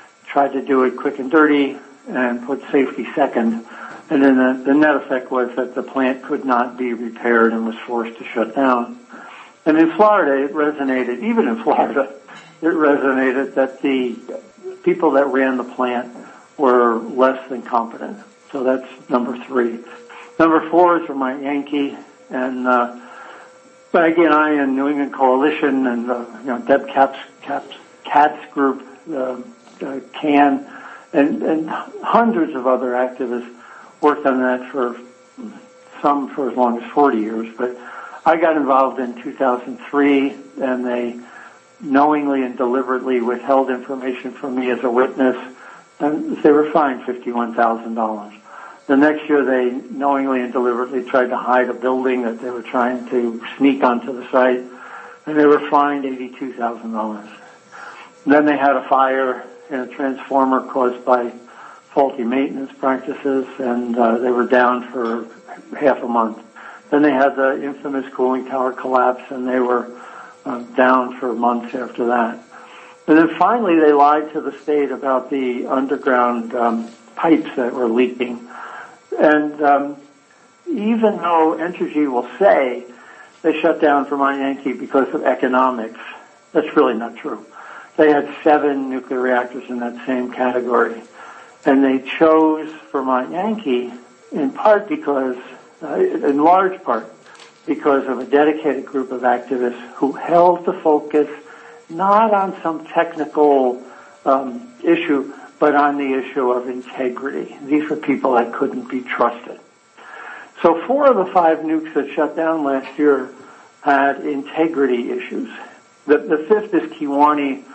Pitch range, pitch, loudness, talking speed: 125-150 Hz, 135 Hz, -18 LUFS, 155 wpm